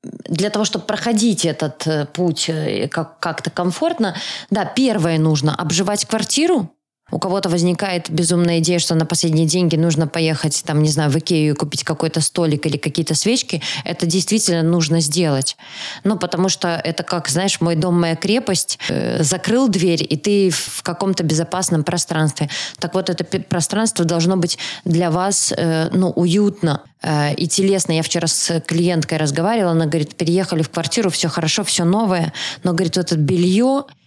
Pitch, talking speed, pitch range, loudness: 175 Hz, 155 wpm, 160-190 Hz, -18 LUFS